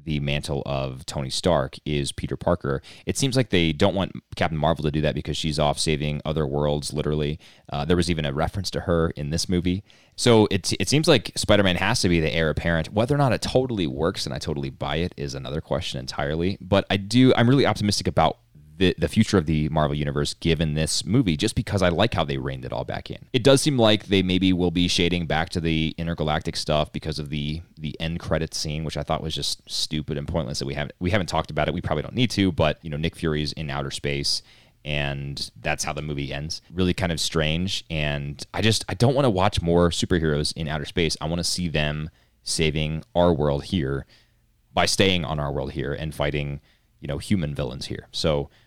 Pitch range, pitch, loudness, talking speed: 75-95 Hz, 80 Hz, -24 LUFS, 235 wpm